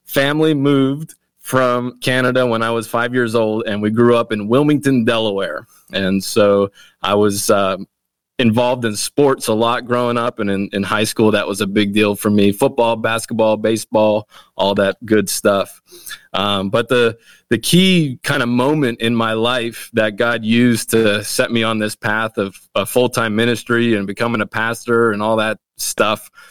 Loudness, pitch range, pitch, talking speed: -16 LUFS, 105-125 Hz, 115 Hz, 180 wpm